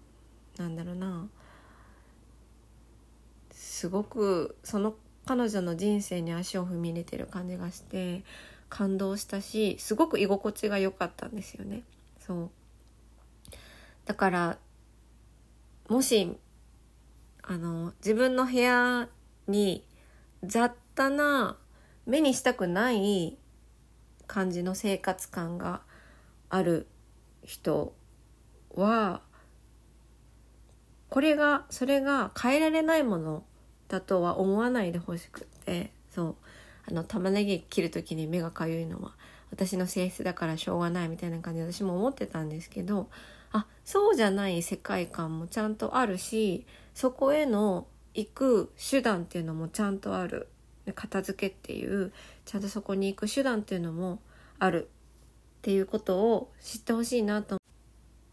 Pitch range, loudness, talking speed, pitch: 175-225 Hz, -30 LUFS, 250 characters per minute, 195 Hz